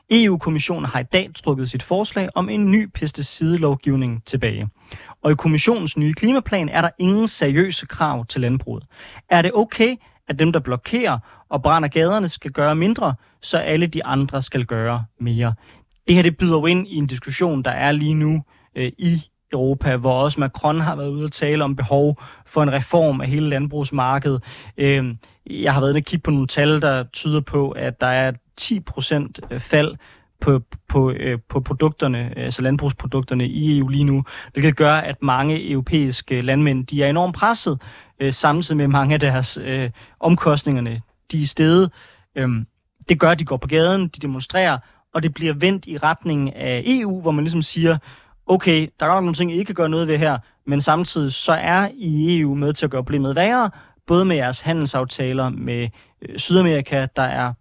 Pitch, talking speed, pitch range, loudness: 145 Hz, 185 wpm, 130-165 Hz, -19 LUFS